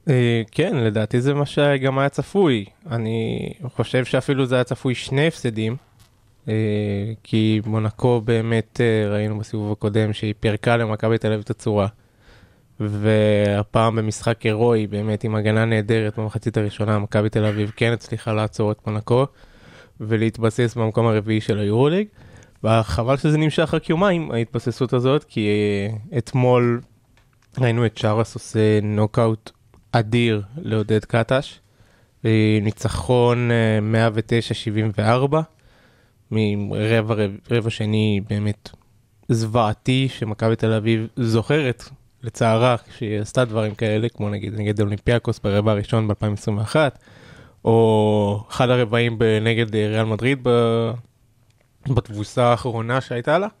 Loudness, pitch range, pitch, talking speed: -21 LUFS, 110-120 Hz, 115 Hz, 115 wpm